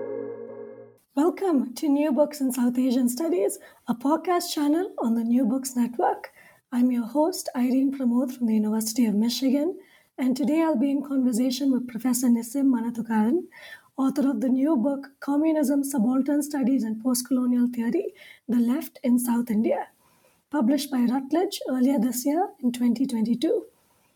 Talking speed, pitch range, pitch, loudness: 150 wpm, 245-305 Hz, 270 Hz, -25 LUFS